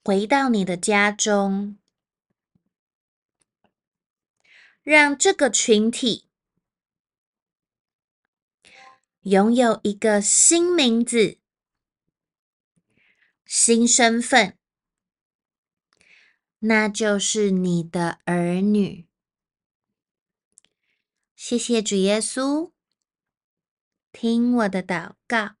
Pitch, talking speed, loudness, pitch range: 220 Hz, 90 characters per minute, -19 LUFS, 200-240 Hz